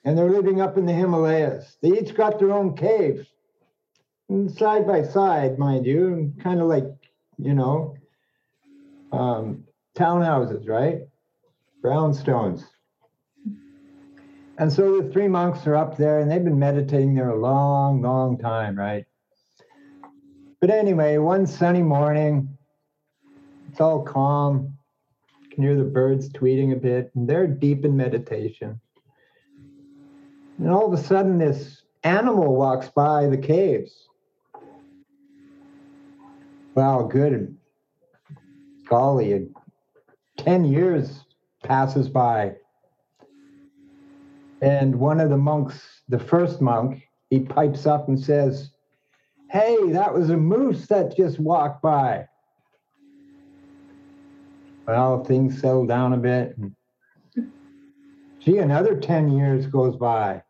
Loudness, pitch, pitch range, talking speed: -21 LUFS, 155 Hz, 135-220 Hz, 120 wpm